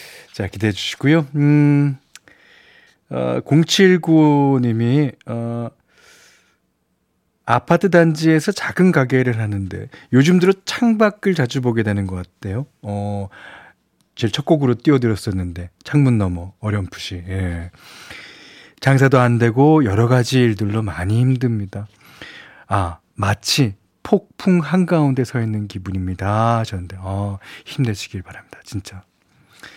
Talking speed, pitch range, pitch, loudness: 235 characters per minute, 100-145 Hz, 120 Hz, -18 LUFS